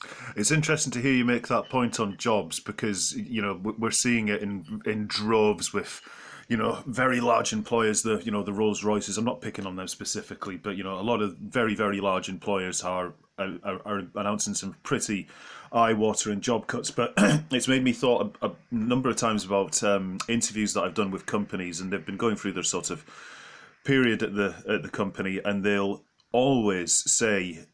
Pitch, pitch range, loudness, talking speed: 105 Hz, 100-120 Hz, -27 LUFS, 200 wpm